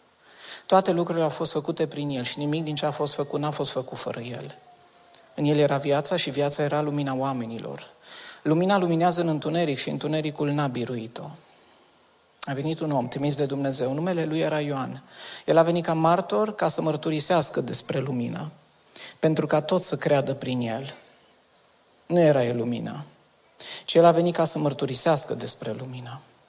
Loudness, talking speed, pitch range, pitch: -24 LUFS, 175 wpm, 135-165 Hz, 150 Hz